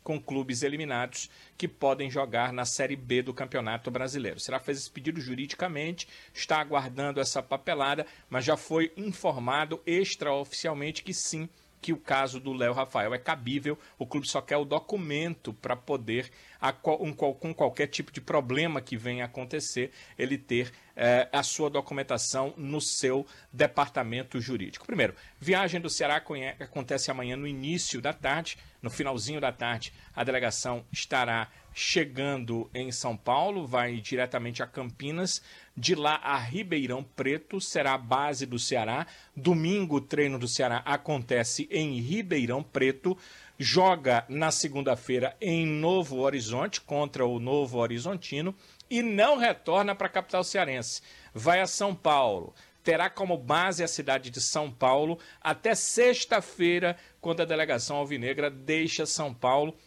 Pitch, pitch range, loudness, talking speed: 140 Hz, 130-165 Hz, -29 LUFS, 145 wpm